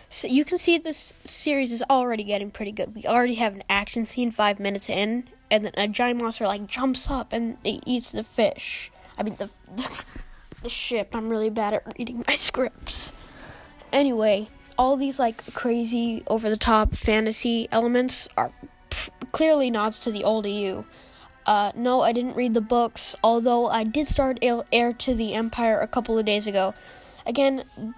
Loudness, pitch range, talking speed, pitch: -24 LUFS, 215-250 Hz, 185 wpm, 230 Hz